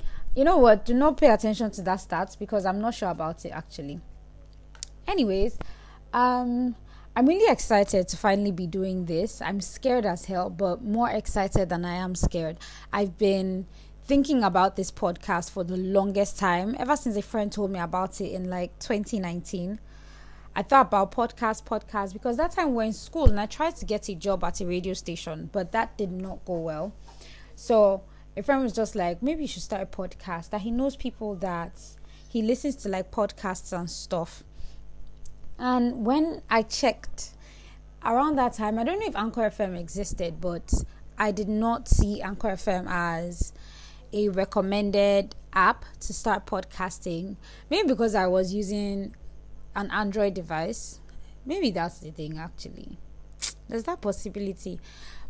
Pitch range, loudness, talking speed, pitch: 180-225 Hz, -27 LUFS, 170 wpm, 200 Hz